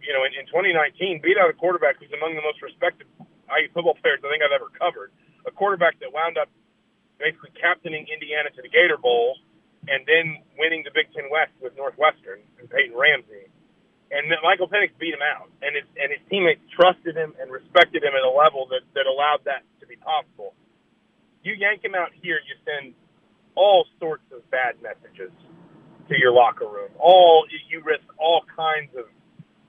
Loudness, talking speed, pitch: -21 LUFS, 190 wpm, 165 Hz